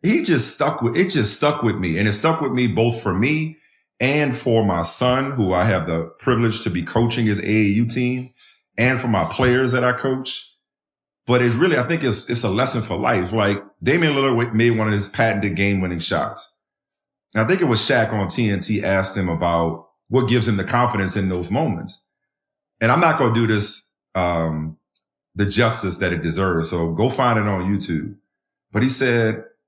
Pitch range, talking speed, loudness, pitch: 95-125 Hz, 205 wpm, -20 LUFS, 110 Hz